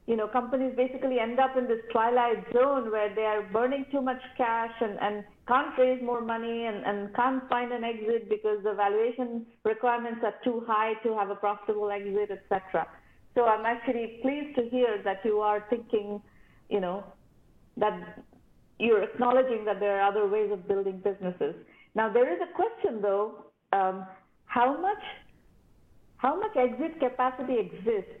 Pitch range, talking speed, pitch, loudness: 210-250 Hz, 170 wpm, 230 Hz, -29 LUFS